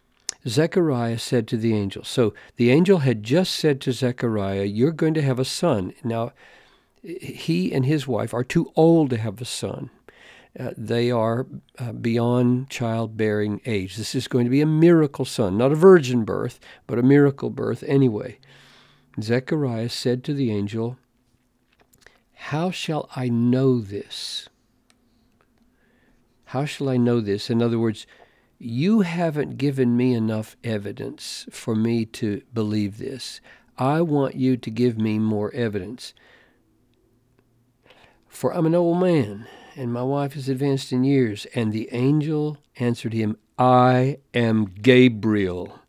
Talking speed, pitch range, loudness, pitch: 145 wpm, 115-140 Hz, -22 LUFS, 125 Hz